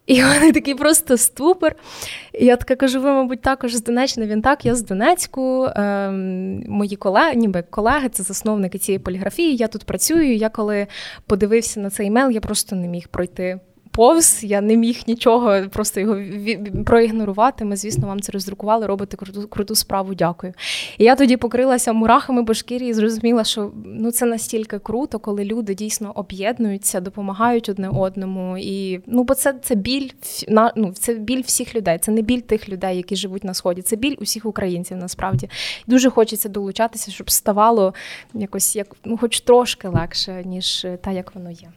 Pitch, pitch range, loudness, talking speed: 215 Hz, 195-240 Hz, -19 LUFS, 170 wpm